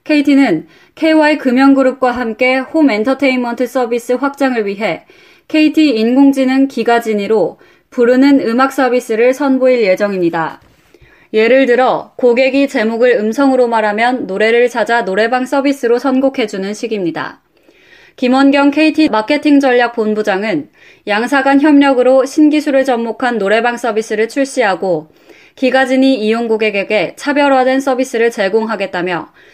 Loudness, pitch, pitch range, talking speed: -12 LUFS, 255 Hz, 225-275 Hz, 315 characters per minute